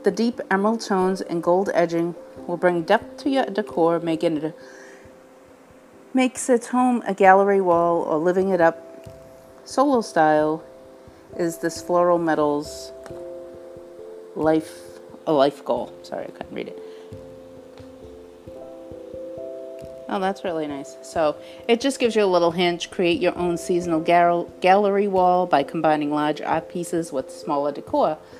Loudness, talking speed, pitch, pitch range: -21 LUFS, 145 wpm, 170 Hz, 135-185 Hz